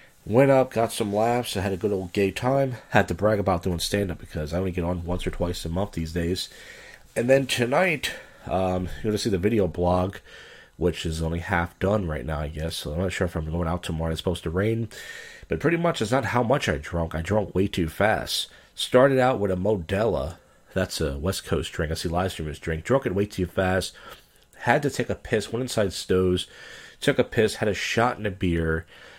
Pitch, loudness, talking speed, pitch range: 95 Hz, -25 LUFS, 235 wpm, 85-110 Hz